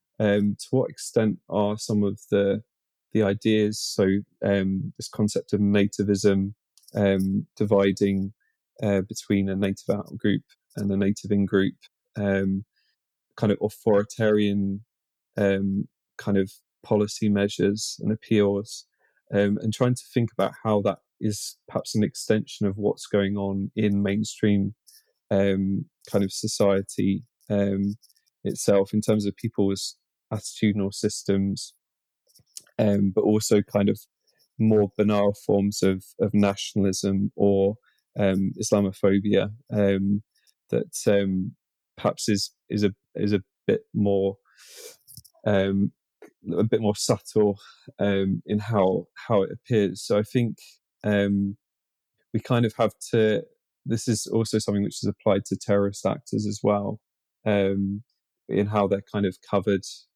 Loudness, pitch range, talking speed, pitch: -25 LUFS, 100-105 Hz, 135 wpm, 100 Hz